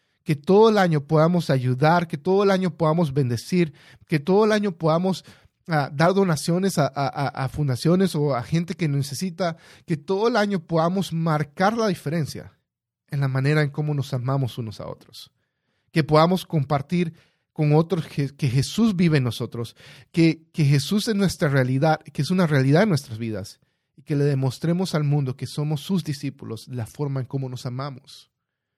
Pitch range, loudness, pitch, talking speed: 135-175 Hz, -22 LUFS, 155 Hz, 180 wpm